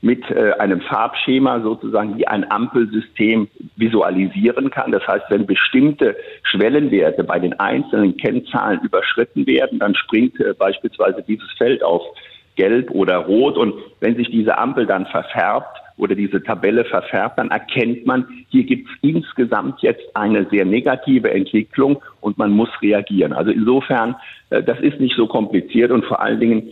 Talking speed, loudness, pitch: 150 wpm, -17 LUFS, 130 Hz